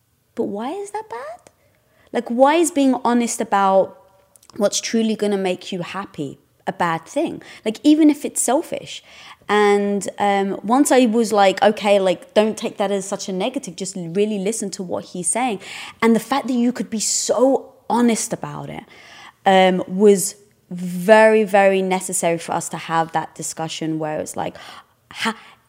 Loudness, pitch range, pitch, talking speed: -19 LUFS, 185-235 Hz, 205 Hz, 175 wpm